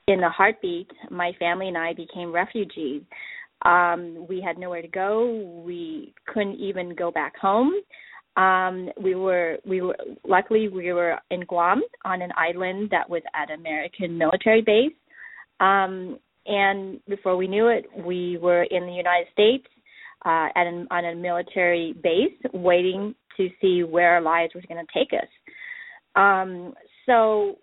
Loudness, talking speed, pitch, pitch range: -23 LUFS, 155 wpm, 185 Hz, 175-205 Hz